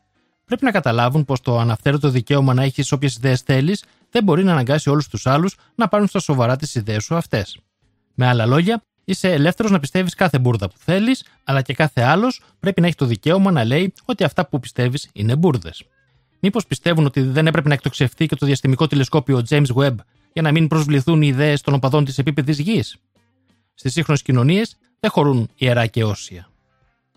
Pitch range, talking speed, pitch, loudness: 125-170 Hz, 190 wpm, 145 Hz, -18 LUFS